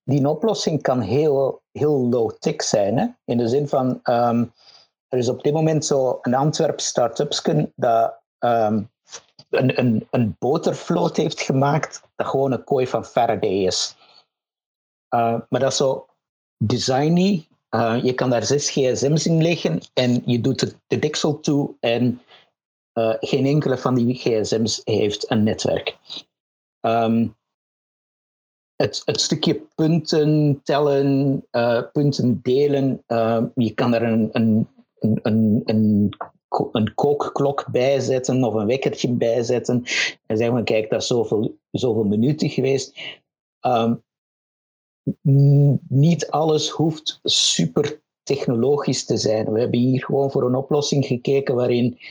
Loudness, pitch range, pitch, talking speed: -20 LUFS, 120-145 Hz, 130 Hz, 140 wpm